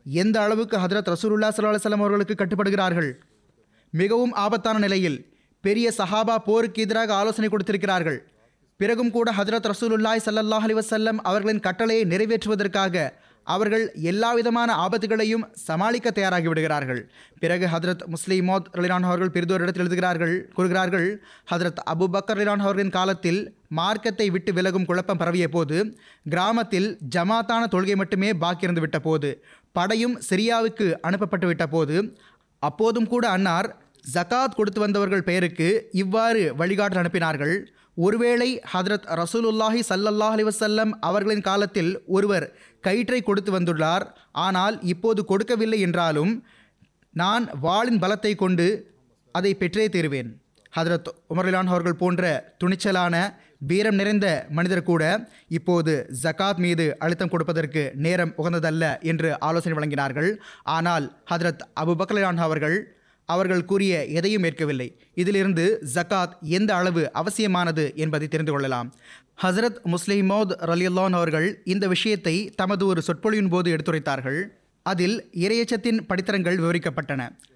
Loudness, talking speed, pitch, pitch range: -23 LUFS, 110 wpm, 185 Hz, 170-215 Hz